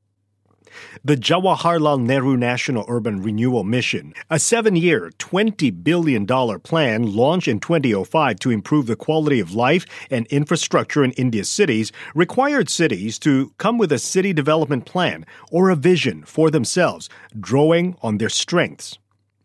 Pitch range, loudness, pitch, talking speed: 115-170 Hz, -19 LUFS, 145 Hz, 140 wpm